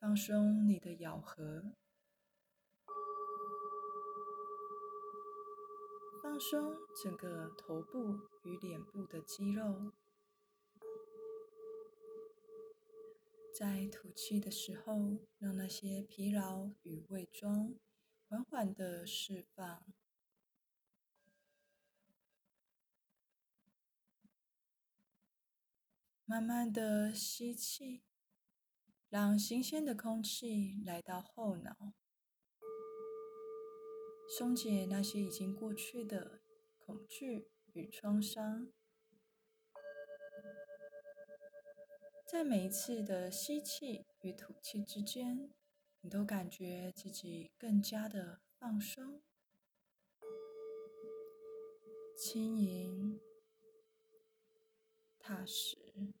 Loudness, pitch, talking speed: -42 LUFS, 220 Hz, 100 characters per minute